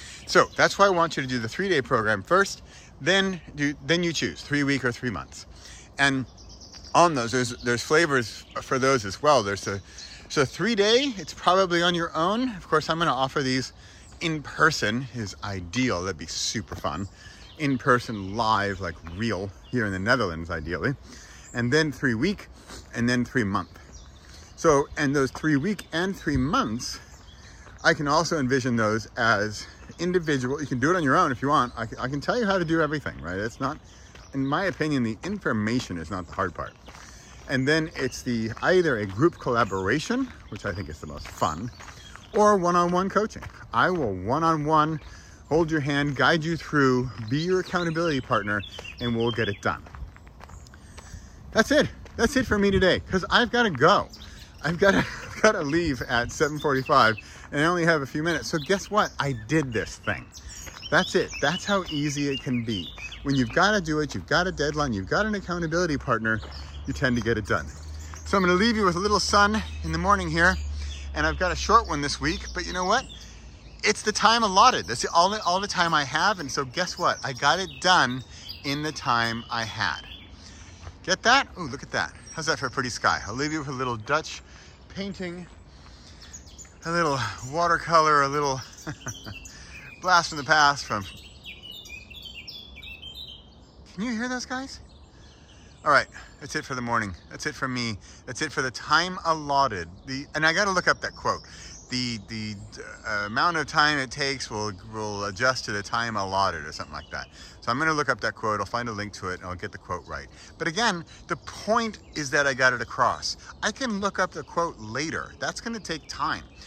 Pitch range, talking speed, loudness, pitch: 100-165 Hz, 200 wpm, -25 LUFS, 130 Hz